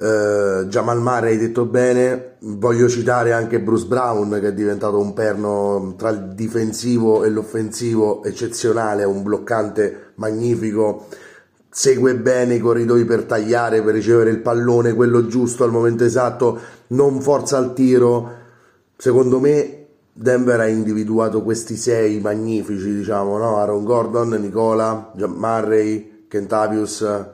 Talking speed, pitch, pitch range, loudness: 130 wpm, 115 Hz, 110-120 Hz, -18 LUFS